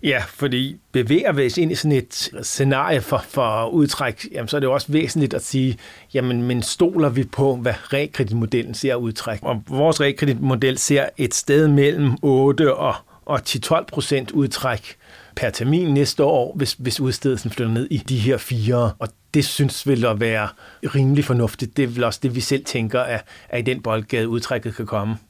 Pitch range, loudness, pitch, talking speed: 115-140 Hz, -20 LUFS, 130 Hz, 190 wpm